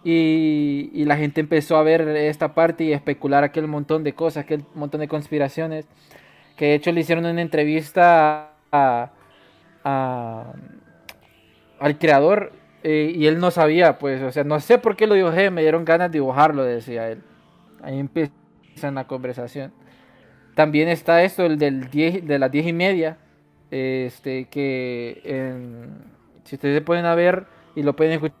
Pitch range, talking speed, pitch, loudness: 140-165 Hz, 165 wpm, 150 Hz, -20 LUFS